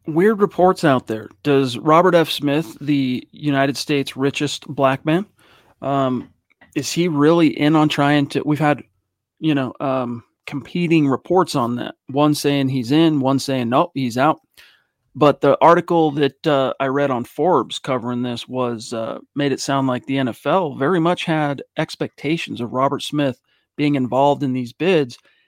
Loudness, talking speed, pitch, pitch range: -19 LUFS, 170 wpm, 140 Hz, 130-155 Hz